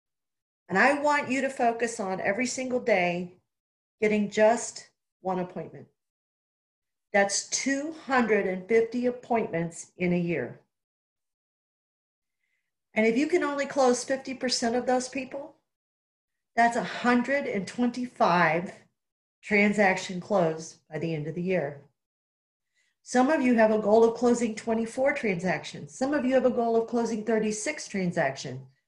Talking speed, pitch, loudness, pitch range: 125 wpm, 225 Hz, -26 LUFS, 180-250 Hz